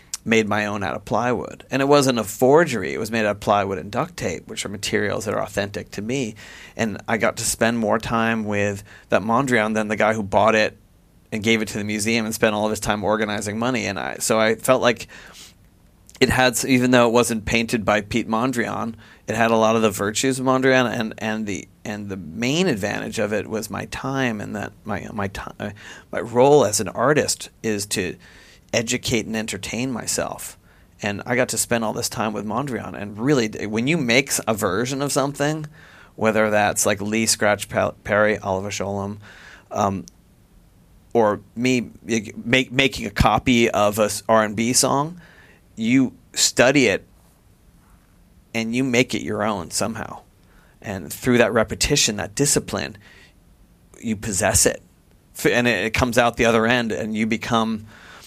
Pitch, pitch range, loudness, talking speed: 110 Hz, 105-120 Hz, -21 LUFS, 185 wpm